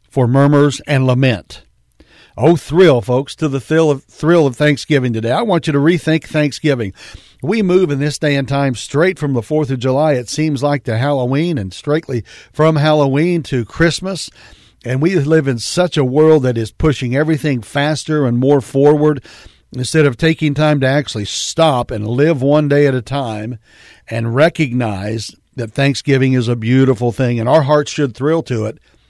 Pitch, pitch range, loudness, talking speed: 145 Hz, 125-155 Hz, -15 LUFS, 185 wpm